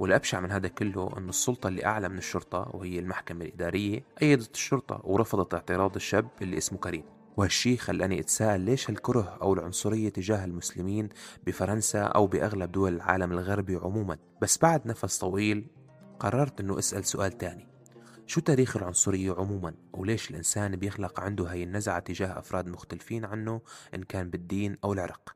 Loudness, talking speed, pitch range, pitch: -30 LUFS, 155 wpm, 90-110 Hz, 100 Hz